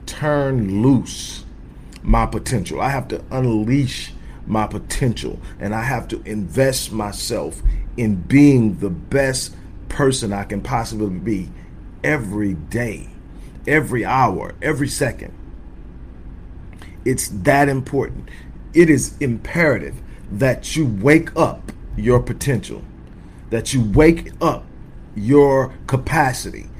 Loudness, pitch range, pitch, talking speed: -19 LUFS, 90-135 Hz, 110 Hz, 110 wpm